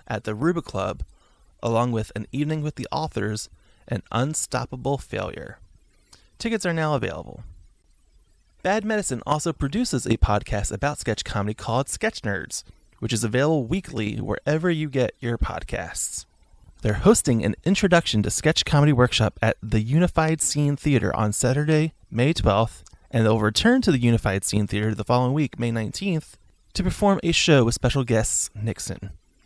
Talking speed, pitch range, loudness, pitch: 155 wpm, 105-150 Hz, -23 LUFS, 115 Hz